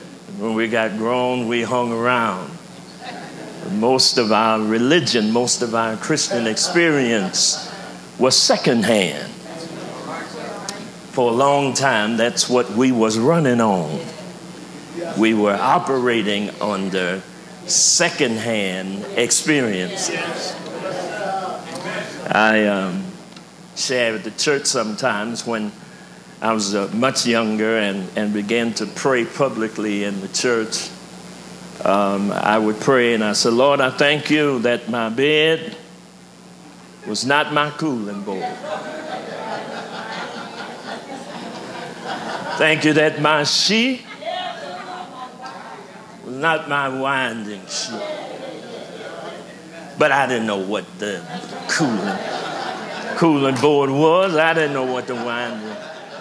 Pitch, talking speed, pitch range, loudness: 125 Hz, 110 wpm, 110-155 Hz, -19 LUFS